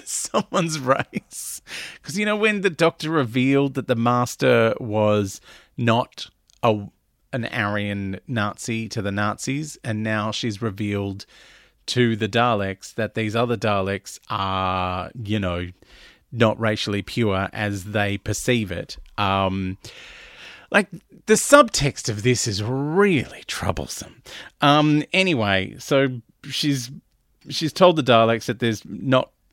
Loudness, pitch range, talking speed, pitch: -22 LUFS, 105-140 Hz, 125 wpm, 115 Hz